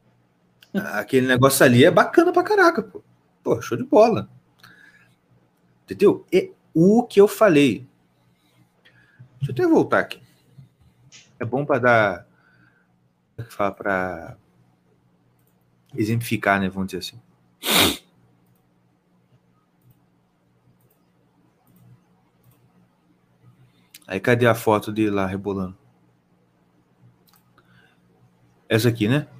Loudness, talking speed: -20 LUFS, 90 wpm